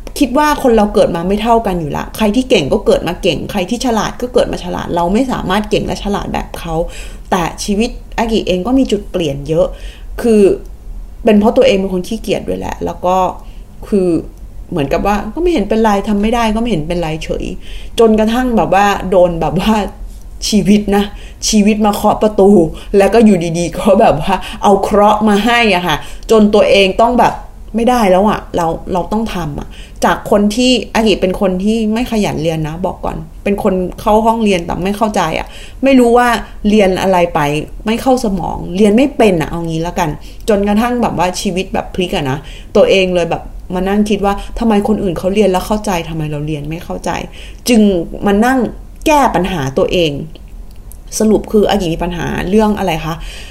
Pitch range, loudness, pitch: 180-220 Hz, -13 LUFS, 200 Hz